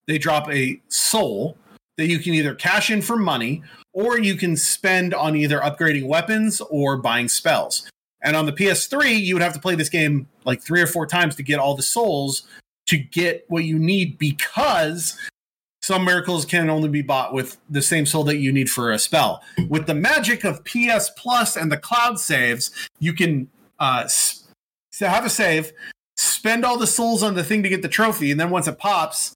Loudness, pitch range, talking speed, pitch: -20 LUFS, 150-200 Hz, 200 wpm, 165 Hz